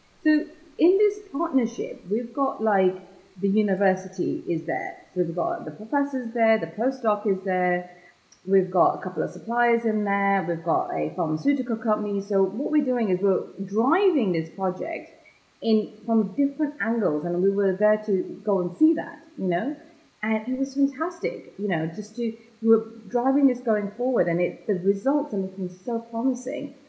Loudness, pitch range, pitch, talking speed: -25 LUFS, 190-260 Hz, 215 Hz, 180 wpm